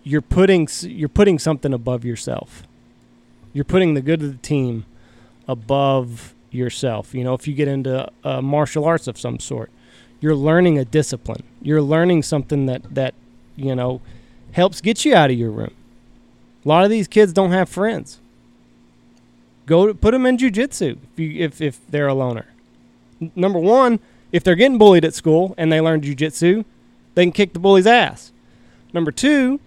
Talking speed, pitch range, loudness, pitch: 180 wpm, 120-175 Hz, -17 LUFS, 145 Hz